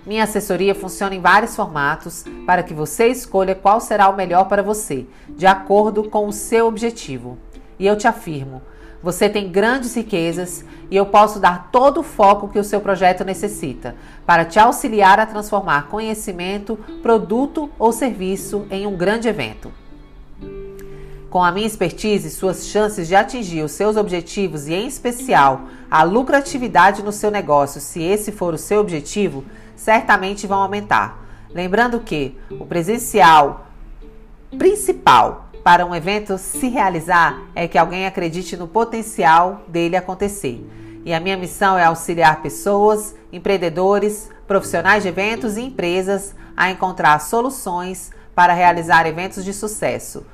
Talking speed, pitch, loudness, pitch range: 145 wpm, 195 Hz, -17 LUFS, 170-210 Hz